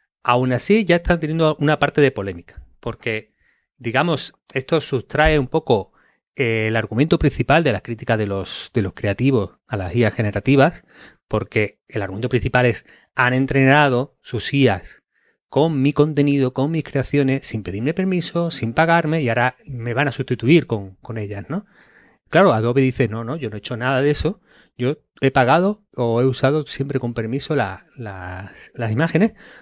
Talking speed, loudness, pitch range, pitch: 175 wpm, -19 LUFS, 115-150 Hz, 130 Hz